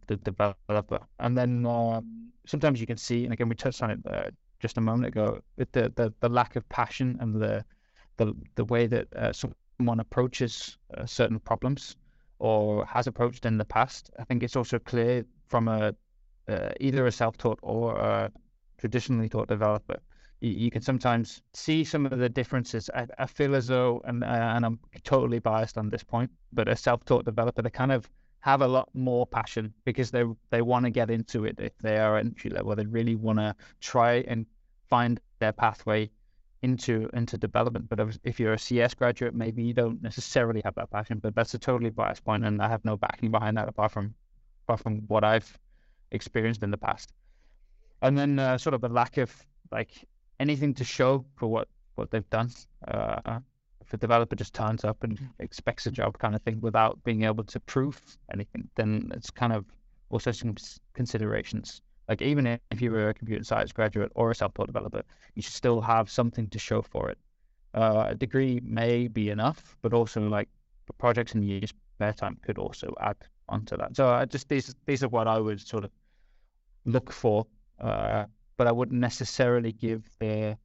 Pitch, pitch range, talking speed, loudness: 115 Hz, 110-125 Hz, 195 wpm, -29 LUFS